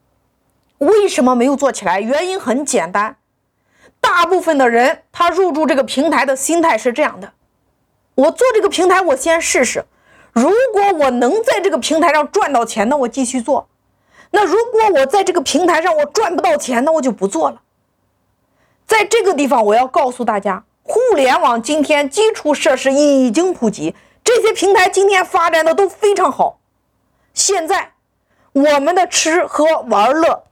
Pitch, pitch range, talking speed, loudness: 325 Hz, 275-380 Hz, 250 characters per minute, -14 LUFS